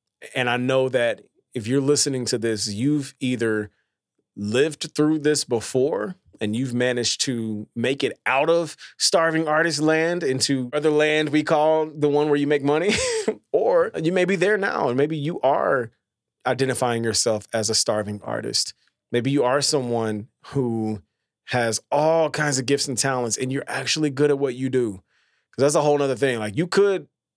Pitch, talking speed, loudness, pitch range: 135 Hz, 180 wpm, -22 LUFS, 120-150 Hz